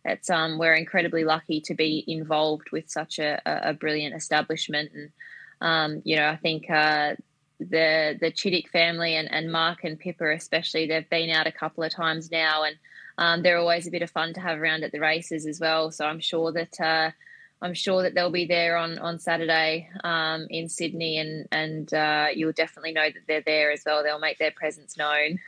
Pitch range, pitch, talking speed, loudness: 155-165 Hz, 160 Hz, 205 wpm, -25 LUFS